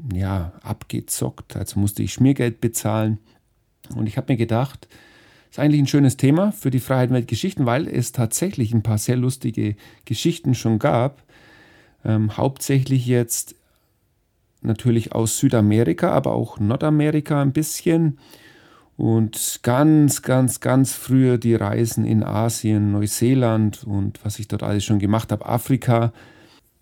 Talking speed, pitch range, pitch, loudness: 140 wpm, 110-135 Hz, 120 Hz, -20 LUFS